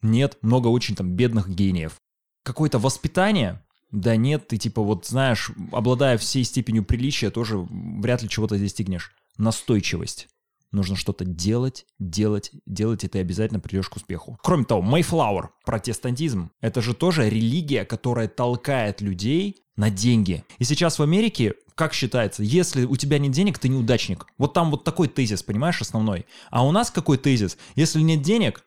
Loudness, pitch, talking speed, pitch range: -23 LUFS, 120 Hz, 160 wpm, 105-140 Hz